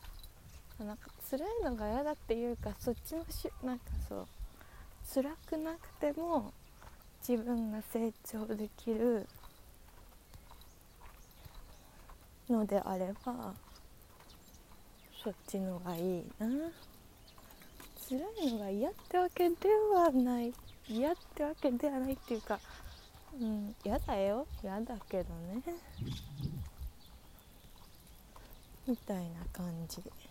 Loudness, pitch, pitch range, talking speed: -37 LUFS, 220 Hz, 175-270 Hz, 190 characters per minute